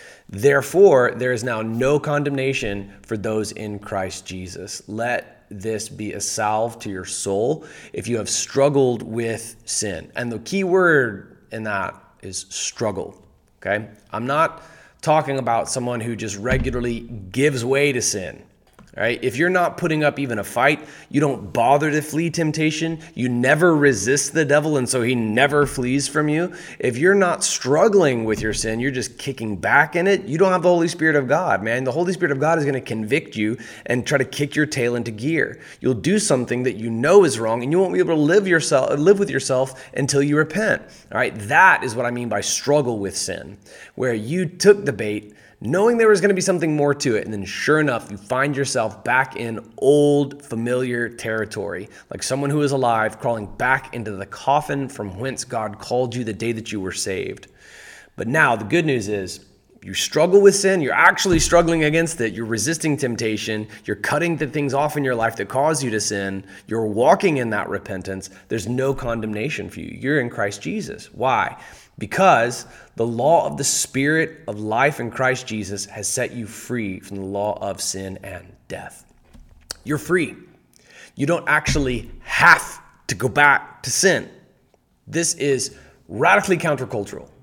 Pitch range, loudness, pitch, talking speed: 110-150 Hz, -20 LUFS, 125 Hz, 190 wpm